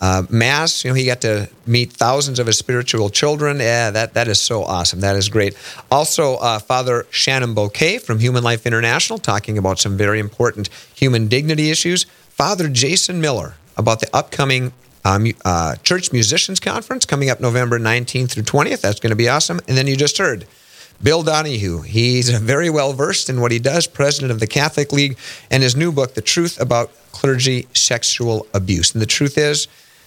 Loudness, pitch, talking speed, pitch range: -16 LUFS, 125 Hz, 190 wpm, 110-145 Hz